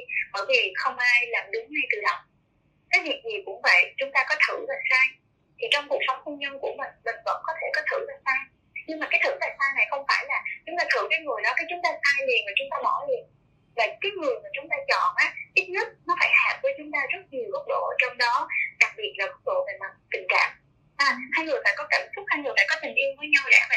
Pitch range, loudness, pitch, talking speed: 270-400 Hz, -24 LUFS, 300 Hz, 275 wpm